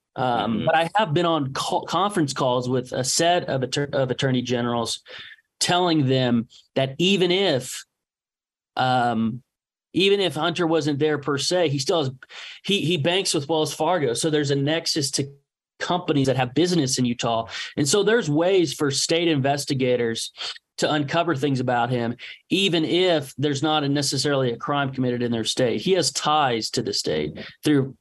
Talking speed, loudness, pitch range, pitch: 170 wpm, -22 LUFS, 130-165 Hz, 145 Hz